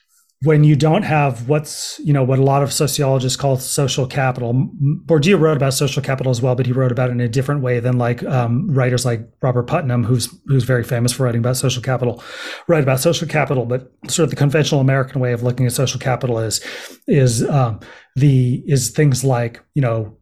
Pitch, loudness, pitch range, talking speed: 130 Hz, -17 LUFS, 125-145 Hz, 215 wpm